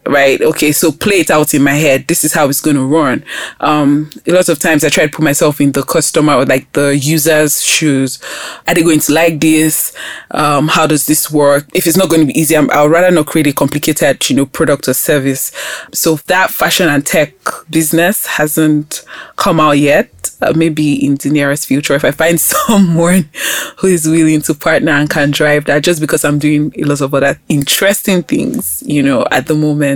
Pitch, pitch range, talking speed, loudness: 155 Hz, 145-165 Hz, 220 wpm, -11 LUFS